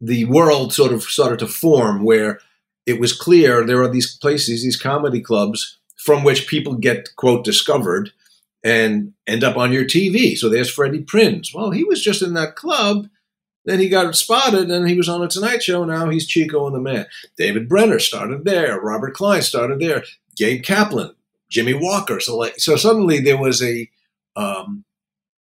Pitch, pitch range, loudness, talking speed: 155 Hz, 125-195 Hz, -17 LUFS, 185 wpm